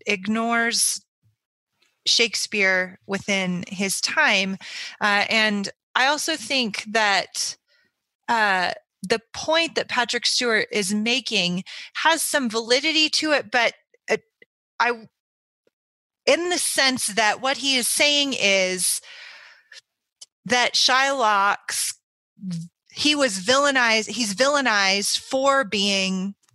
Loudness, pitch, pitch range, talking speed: -20 LUFS, 230 Hz, 200-275 Hz, 100 wpm